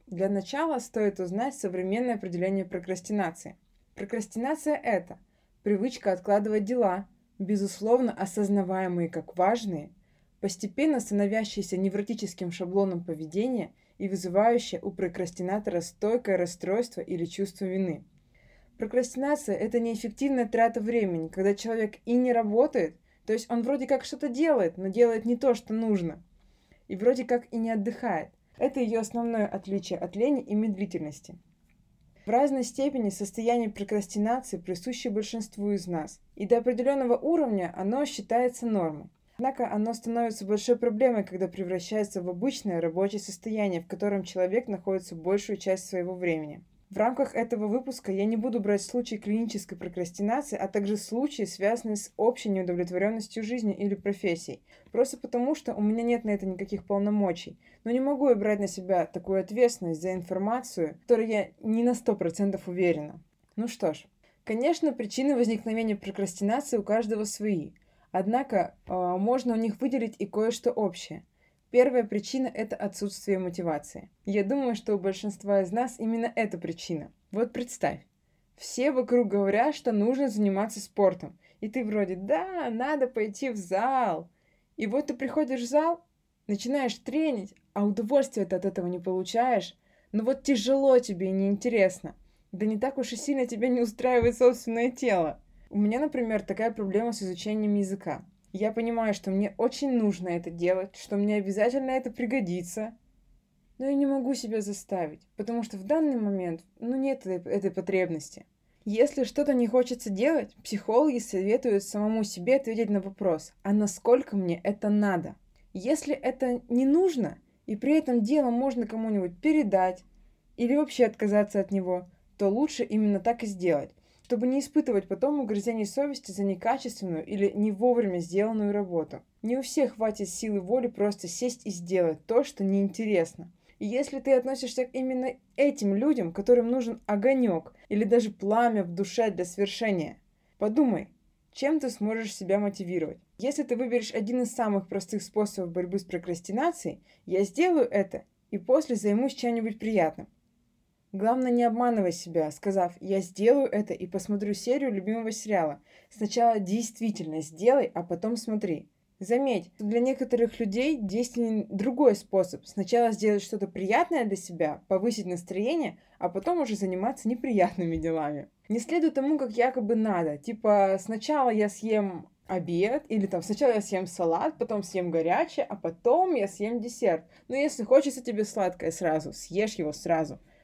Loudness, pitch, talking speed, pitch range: -28 LUFS, 210 Hz, 150 wpm, 190-245 Hz